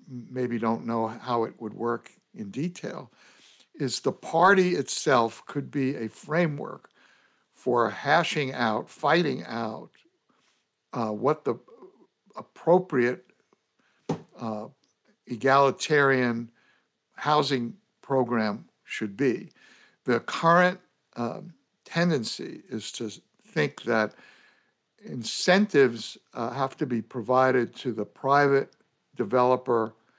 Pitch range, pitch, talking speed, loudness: 115-165 Hz, 130 Hz, 100 wpm, -26 LUFS